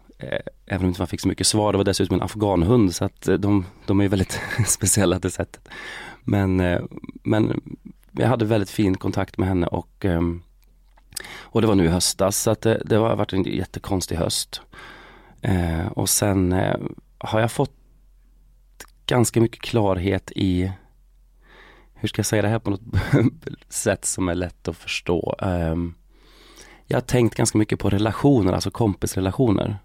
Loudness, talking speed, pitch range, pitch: -22 LUFS, 160 wpm, 95-110 Hz, 100 Hz